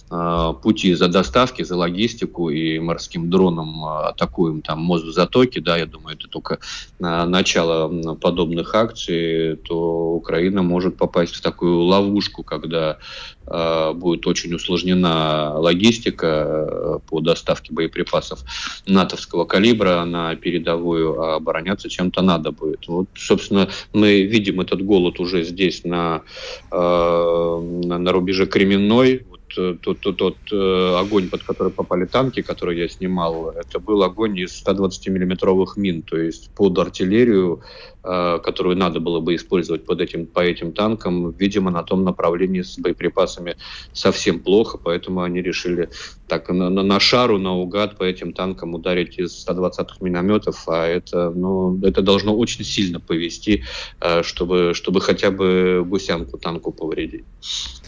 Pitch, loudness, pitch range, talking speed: 90 Hz, -19 LUFS, 85-95 Hz, 135 wpm